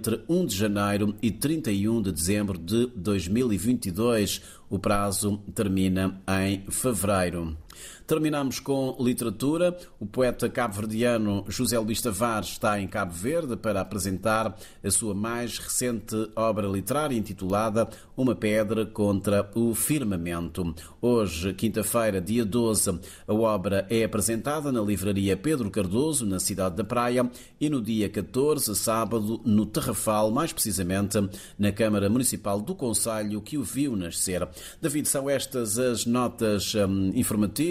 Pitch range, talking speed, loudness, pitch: 100-120 Hz, 130 wpm, -26 LUFS, 110 Hz